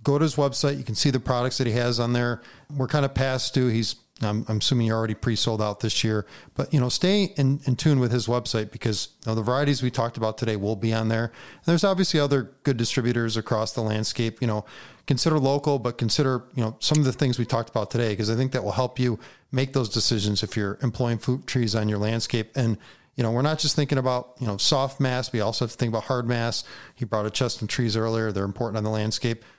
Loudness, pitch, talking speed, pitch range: -25 LUFS, 120 Hz, 255 wpm, 110-130 Hz